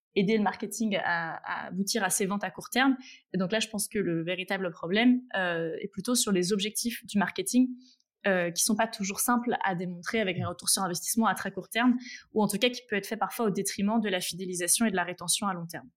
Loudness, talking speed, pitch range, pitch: -28 LUFS, 240 wpm, 185-230 Hz, 200 Hz